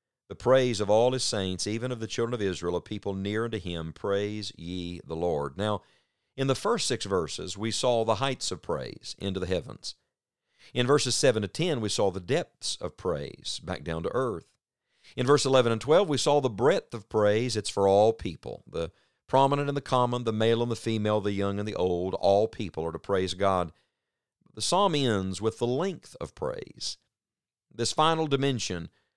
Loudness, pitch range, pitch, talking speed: -28 LUFS, 95-125 Hz, 110 Hz, 200 wpm